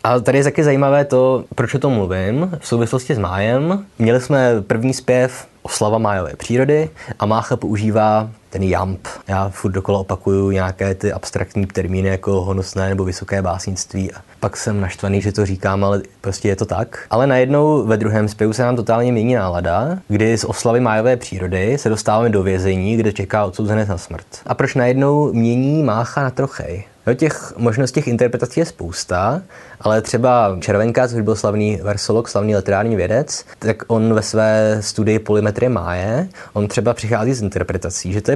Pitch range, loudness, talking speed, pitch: 100-125 Hz, -17 LUFS, 180 wpm, 110 Hz